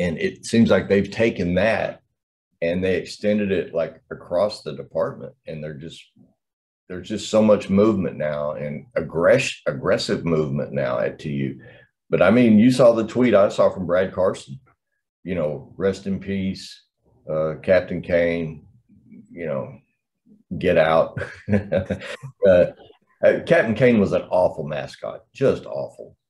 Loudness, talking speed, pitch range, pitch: -21 LUFS, 145 wpm, 80-105 Hz, 95 Hz